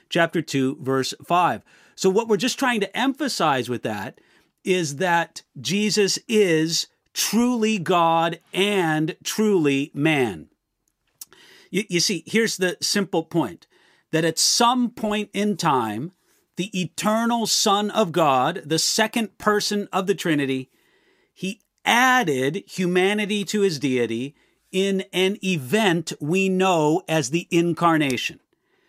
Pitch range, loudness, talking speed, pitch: 165-210 Hz, -22 LUFS, 125 wpm, 185 Hz